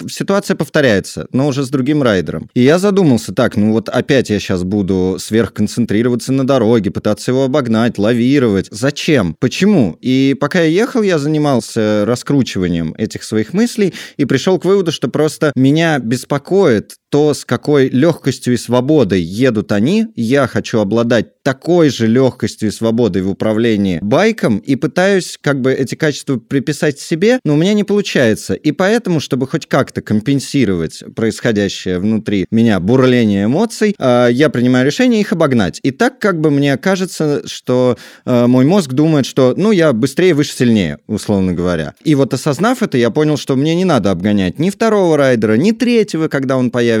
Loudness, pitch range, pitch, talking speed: -14 LUFS, 115-160 Hz, 135 Hz, 165 wpm